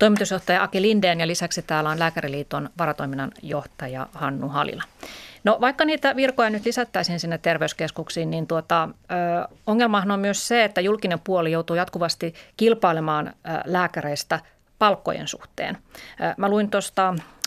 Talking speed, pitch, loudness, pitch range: 135 wpm, 175 Hz, -23 LUFS, 165-205 Hz